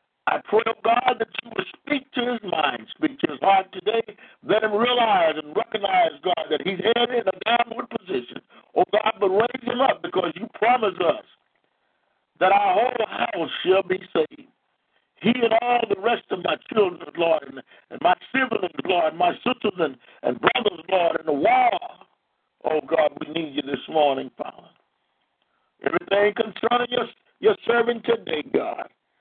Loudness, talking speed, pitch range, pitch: -23 LUFS, 175 wpm, 185-245 Hz, 225 Hz